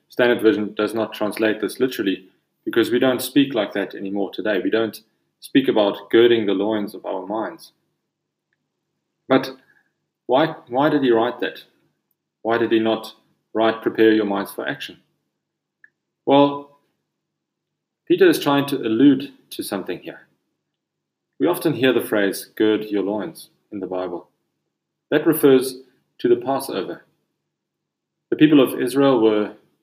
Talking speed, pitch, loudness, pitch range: 145 wpm, 120 Hz, -20 LUFS, 105-145 Hz